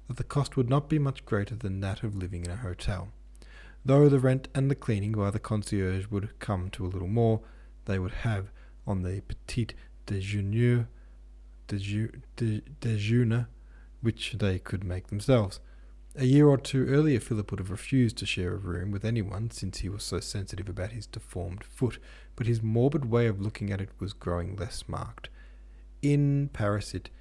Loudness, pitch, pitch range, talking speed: -29 LUFS, 105 Hz, 95-120 Hz, 180 wpm